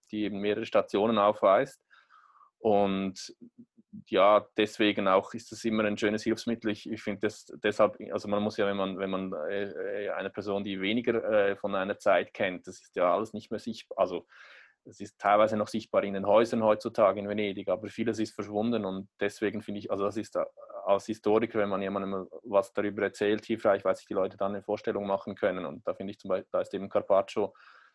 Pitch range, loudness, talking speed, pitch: 100-110 Hz, -29 LUFS, 200 wpm, 105 Hz